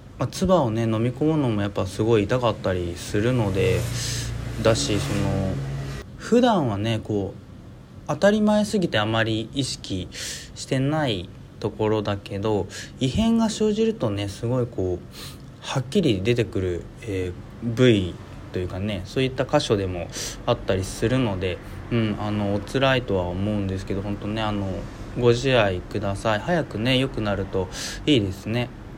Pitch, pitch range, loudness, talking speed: 110 Hz, 100-125 Hz, -24 LUFS, 300 characters per minute